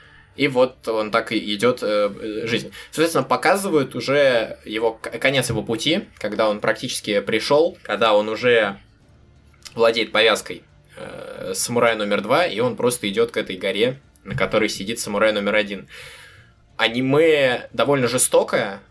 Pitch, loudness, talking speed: 115 Hz, -20 LUFS, 145 wpm